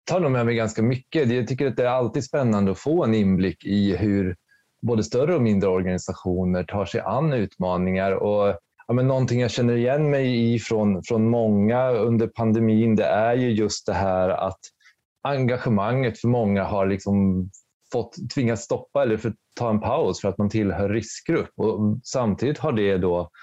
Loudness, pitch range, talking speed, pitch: -23 LUFS, 100-120 Hz, 185 wpm, 110 Hz